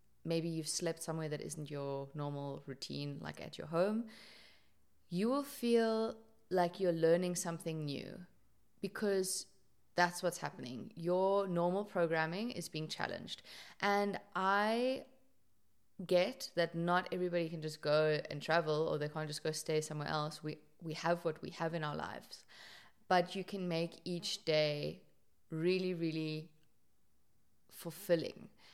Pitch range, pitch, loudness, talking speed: 155-185 Hz, 170 Hz, -37 LUFS, 140 wpm